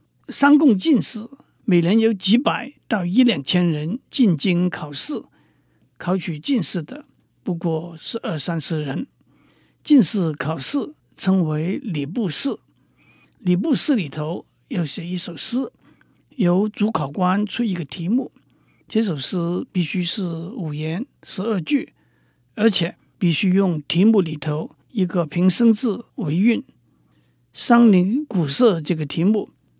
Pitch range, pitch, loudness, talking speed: 165-225 Hz, 185 Hz, -20 LUFS, 185 characters per minute